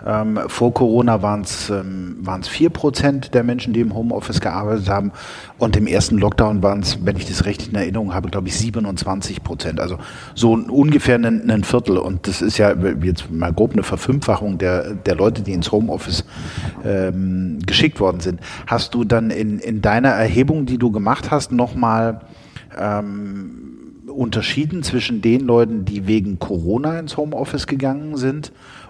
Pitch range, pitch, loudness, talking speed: 100-125 Hz, 110 Hz, -18 LUFS, 170 wpm